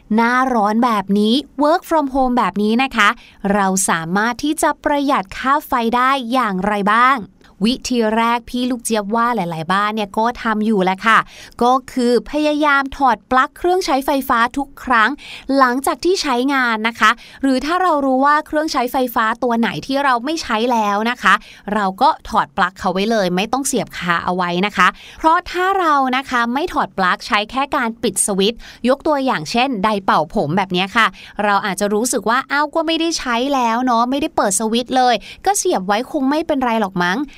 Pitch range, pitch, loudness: 210-275 Hz, 240 Hz, -17 LUFS